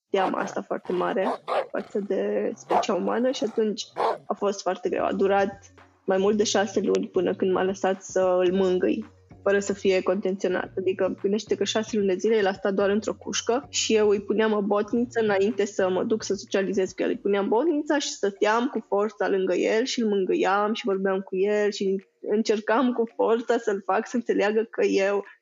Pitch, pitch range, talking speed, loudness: 200 Hz, 190-220 Hz, 200 wpm, -25 LUFS